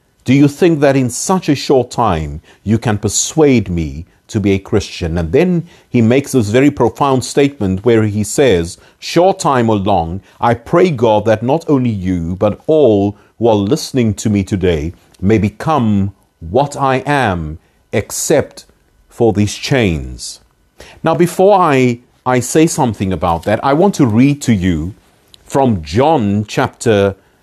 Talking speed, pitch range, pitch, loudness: 160 wpm, 95-140 Hz, 115 Hz, -13 LUFS